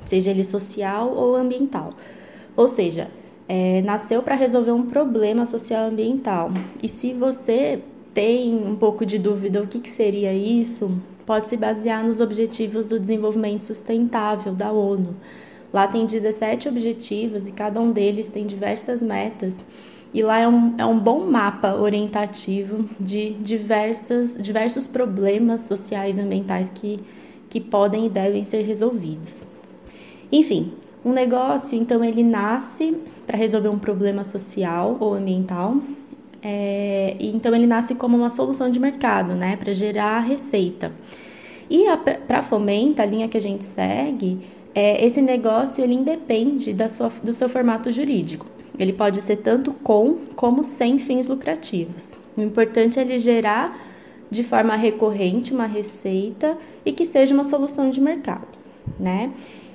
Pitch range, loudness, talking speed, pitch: 205-245 Hz, -21 LUFS, 150 wpm, 225 Hz